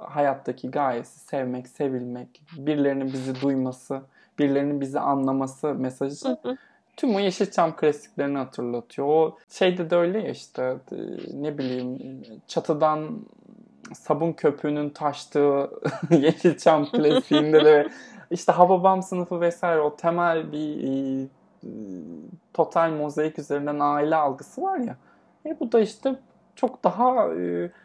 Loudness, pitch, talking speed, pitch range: -24 LUFS, 150 Hz, 115 wpm, 140-180 Hz